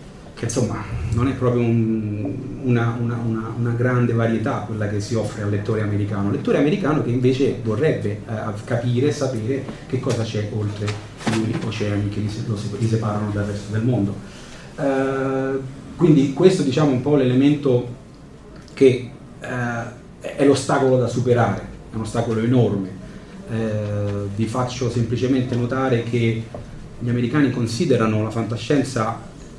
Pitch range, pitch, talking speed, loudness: 110-130 Hz, 120 Hz, 140 wpm, -21 LUFS